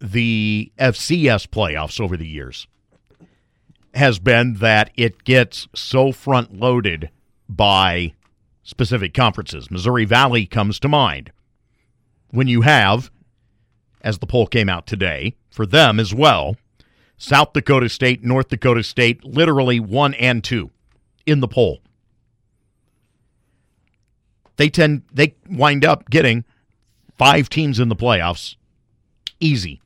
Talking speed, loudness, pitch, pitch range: 120 wpm, -16 LUFS, 120 Hz, 105-130 Hz